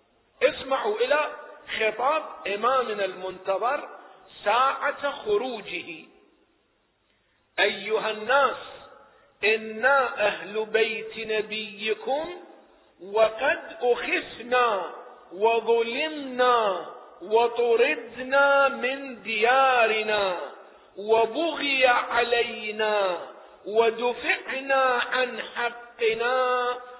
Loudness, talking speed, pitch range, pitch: -25 LUFS, 55 wpm, 220-260 Hz, 235 Hz